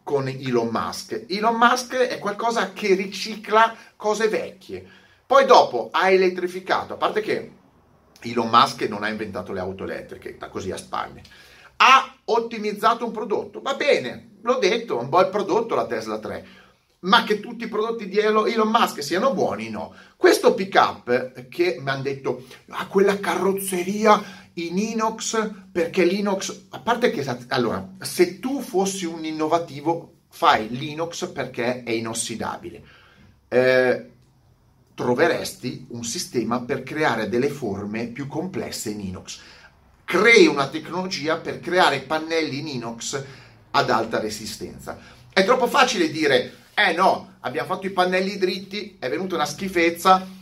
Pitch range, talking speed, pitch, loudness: 140-215 Hz, 145 wpm, 185 Hz, -22 LUFS